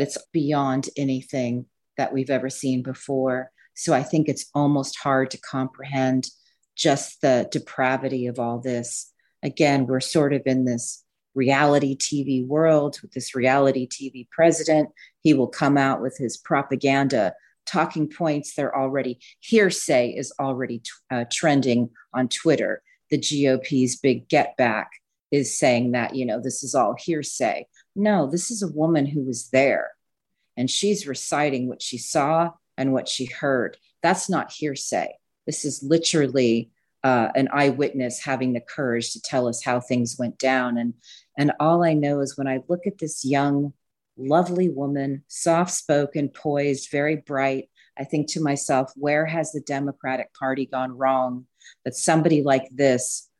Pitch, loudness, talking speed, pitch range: 135 Hz, -23 LUFS, 155 wpm, 130-150 Hz